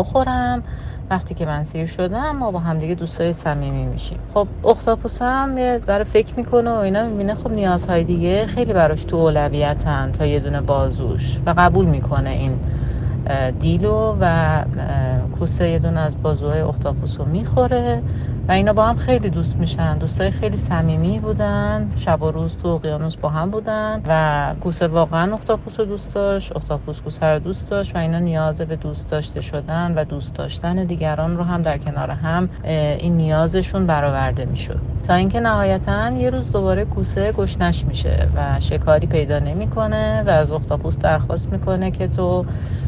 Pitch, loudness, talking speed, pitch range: 155 Hz, -19 LUFS, 160 wpm, 130-175 Hz